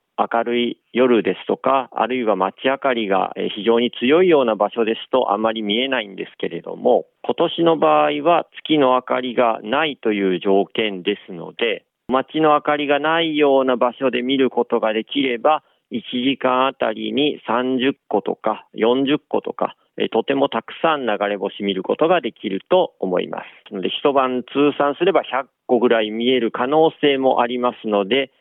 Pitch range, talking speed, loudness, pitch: 110-140 Hz, 315 characters per minute, -19 LUFS, 125 Hz